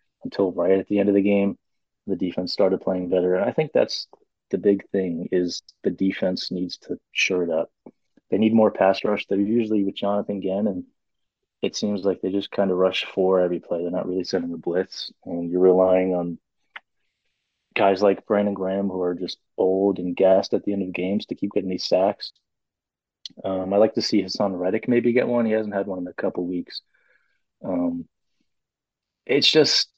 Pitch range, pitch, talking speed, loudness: 90-100 Hz, 95 Hz, 205 wpm, -23 LUFS